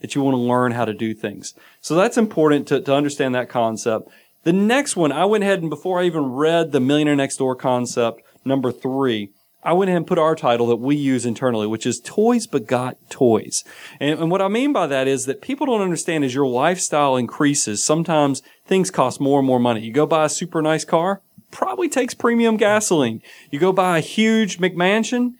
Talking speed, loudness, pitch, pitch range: 215 wpm, -19 LUFS, 150 Hz, 130-185 Hz